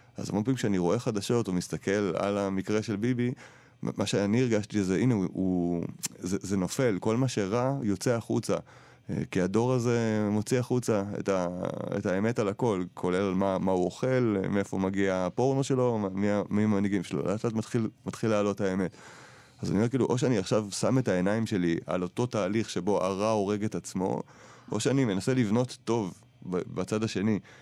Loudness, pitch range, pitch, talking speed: -29 LUFS, 95-120 Hz, 105 Hz, 175 wpm